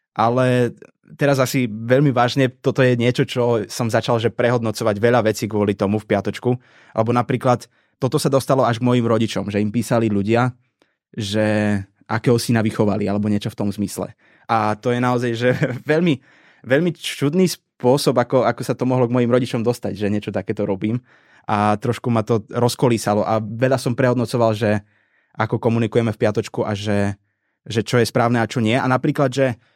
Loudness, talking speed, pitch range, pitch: -19 LUFS, 180 wpm, 110-125 Hz, 120 Hz